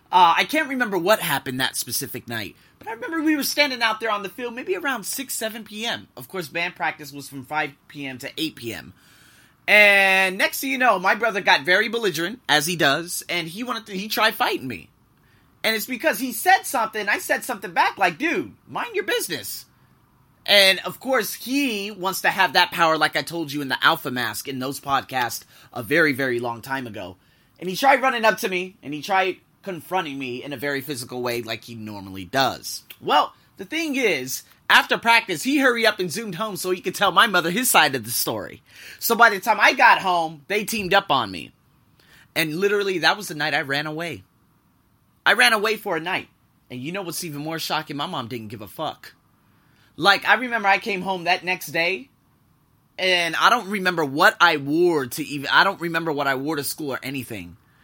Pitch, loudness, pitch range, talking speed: 180 Hz, -21 LUFS, 145-220 Hz, 220 wpm